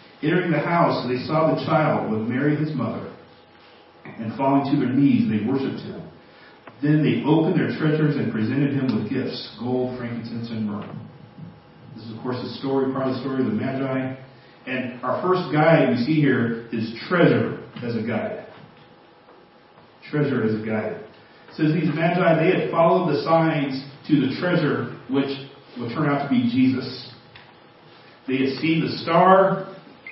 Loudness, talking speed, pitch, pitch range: -22 LUFS, 175 wpm, 140 Hz, 125-160 Hz